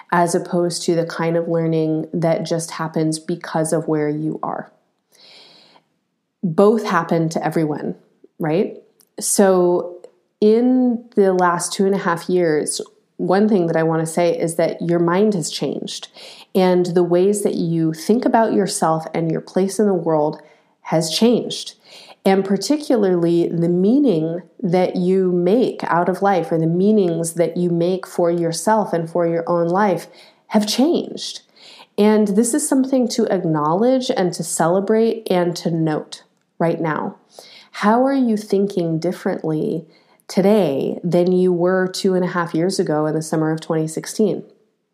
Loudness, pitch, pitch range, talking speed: -18 LUFS, 180 Hz, 165-205 Hz, 155 wpm